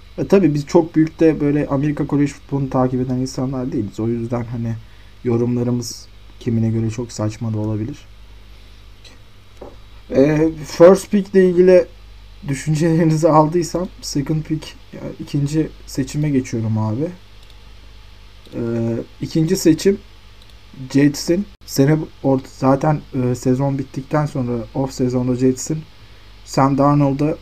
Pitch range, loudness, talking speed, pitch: 110-155 Hz, -18 LUFS, 115 wpm, 130 Hz